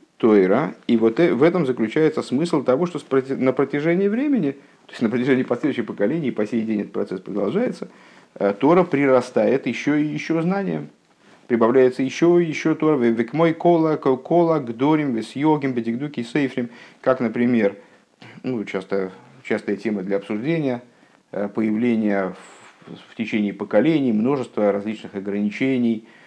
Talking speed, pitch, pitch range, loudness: 120 wpm, 130 Hz, 110-155 Hz, -21 LUFS